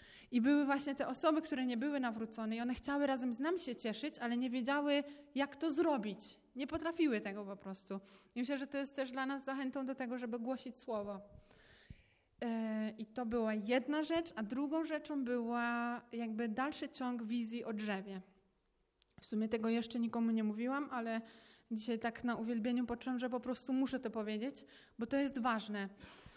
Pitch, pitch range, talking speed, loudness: 245 Hz, 225-275 Hz, 185 wpm, -39 LUFS